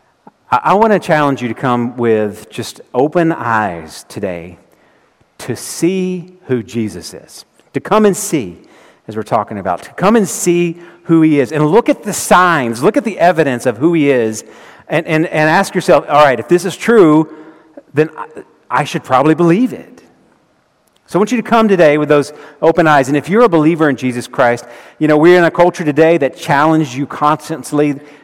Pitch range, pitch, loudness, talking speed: 140-175 Hz, 155 Hz, -13 LUFS, 195 wpm